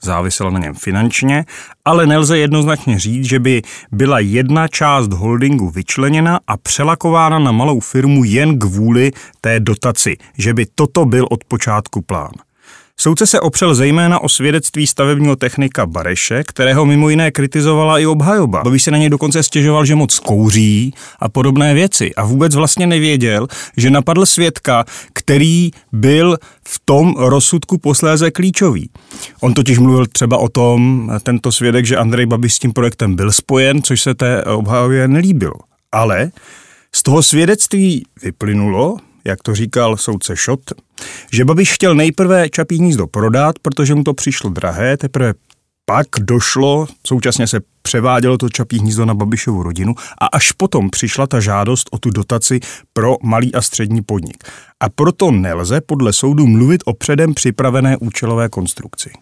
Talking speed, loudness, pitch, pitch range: 155 wpm, -12 LUFS, 130 Hz, 115-150 Hz